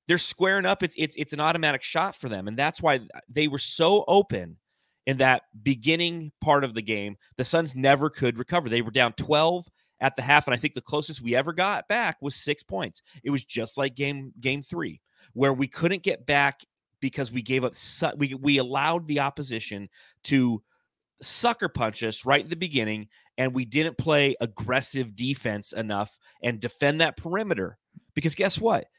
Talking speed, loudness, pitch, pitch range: 190 wpm, -25 LUFS, 140 Hz, 125-155 Hz